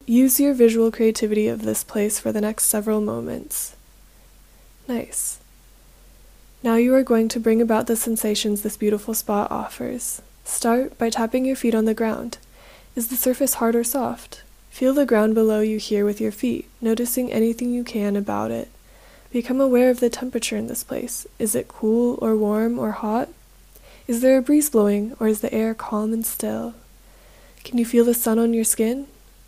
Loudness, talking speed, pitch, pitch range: -21 LUFS, 185 wpm, 230 Hz, 215-245 Hz